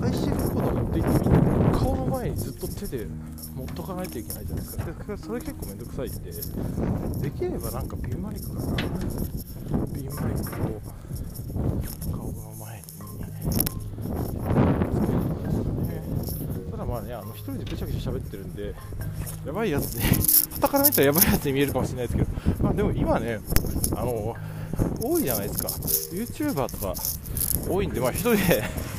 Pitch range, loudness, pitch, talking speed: 95-130 Hz, -26 LUFS, 110 Hz, 330 characters per minute